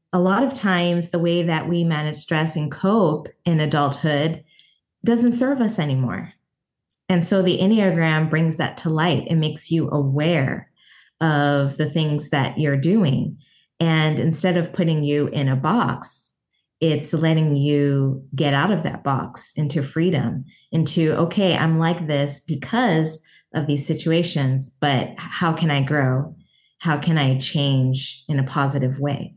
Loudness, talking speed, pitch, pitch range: -20 LUFS, 155 wpm, 155 Hz, 145-170 Hz